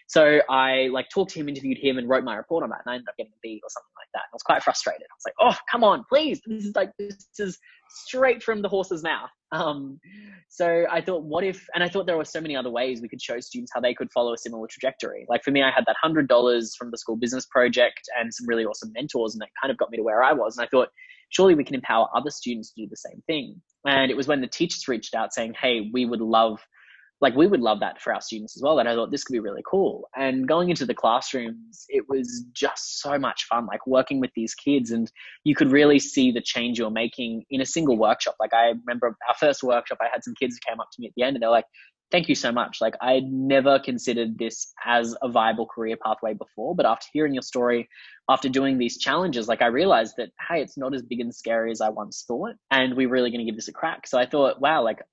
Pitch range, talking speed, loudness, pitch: 120-155 Hz, 270 wpm, -24 LUFS, 130 Hz